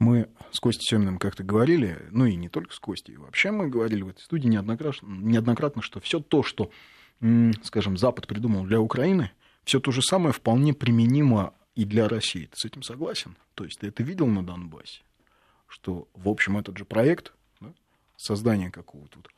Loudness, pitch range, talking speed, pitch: -25 LUFS, 100-125 Hz, 185 wpm, 115 Hz